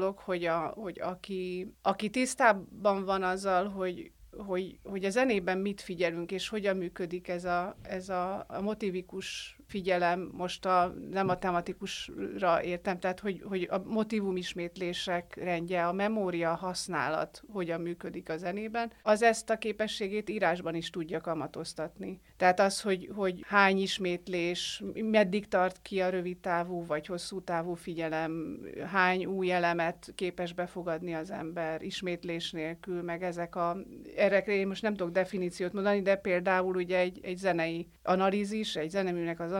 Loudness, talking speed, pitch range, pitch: -32 LUFS, 150 wpm, 175-195 Hz, 185 Hz